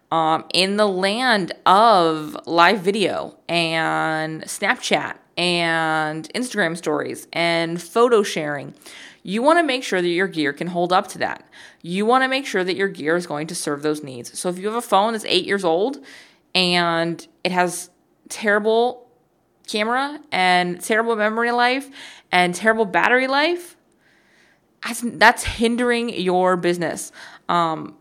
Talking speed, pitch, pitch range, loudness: 150 wpm, 185 Hz, 170-235 Hz, -20 LUFS